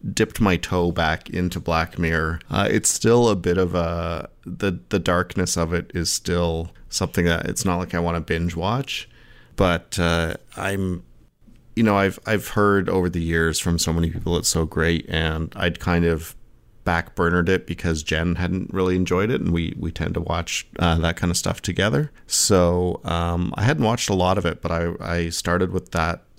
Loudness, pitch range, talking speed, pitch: -22 LUFS, 85-95 Hz, 200 wpm, 85 Hz